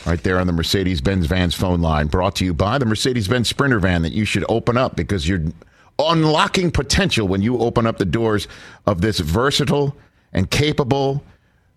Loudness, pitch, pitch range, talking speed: -19 LUFS, 105 Hz, 90-130 Hz, 195 wpm